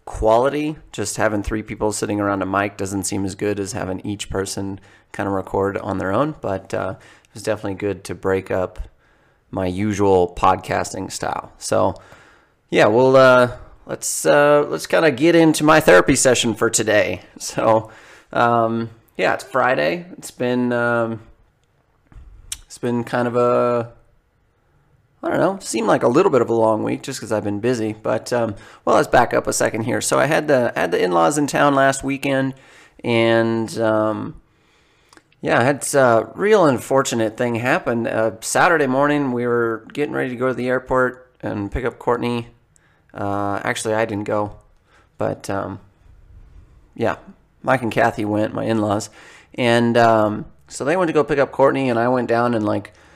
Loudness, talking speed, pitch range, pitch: -19 LUFS, 175 wpm, 105-125 Hz, 115 Hz